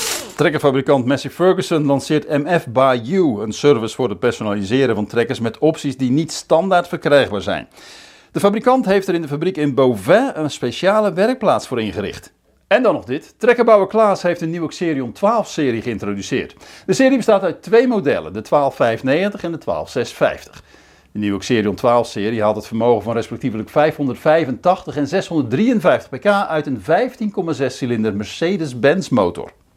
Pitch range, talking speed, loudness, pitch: 125-185 Hz, 160 wpm, -17 LUFS, 150 Hz